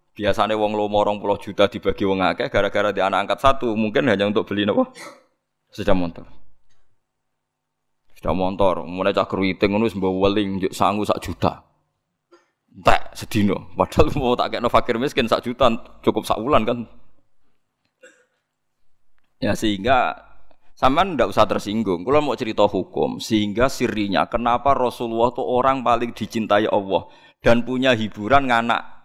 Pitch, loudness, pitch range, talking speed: 105 Hz, -21 LUFS, 100-120 Hz, 145 wpm